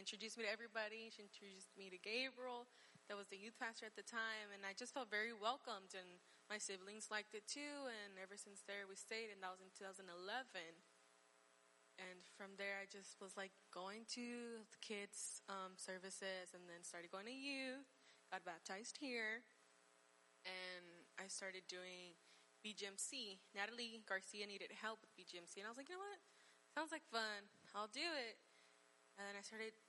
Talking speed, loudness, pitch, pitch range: 180 wpm, -51 LUFS, 200 Hz, 185-225 Hz